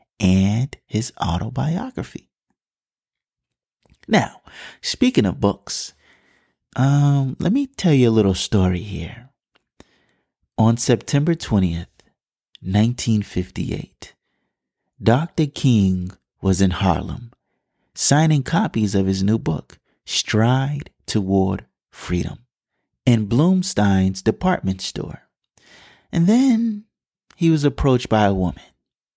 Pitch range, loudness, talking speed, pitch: 95-145 Hz, -20 LUFS, 95 wpm, 110 Hz